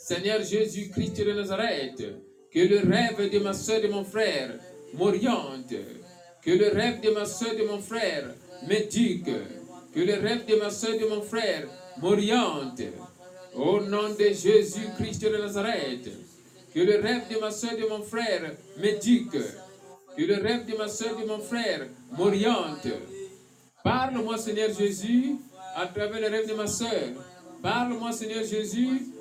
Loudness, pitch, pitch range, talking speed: -27 LUFS, 215 Hz, 205-230 Hz, 165 wpm